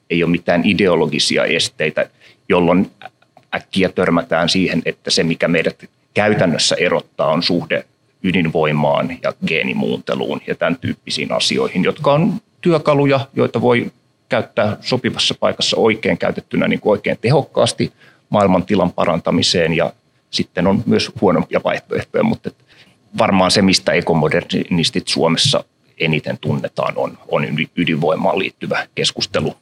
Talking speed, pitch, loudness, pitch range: 120 wpm, 120 Hz, -17 LUFS, 90-145 Hz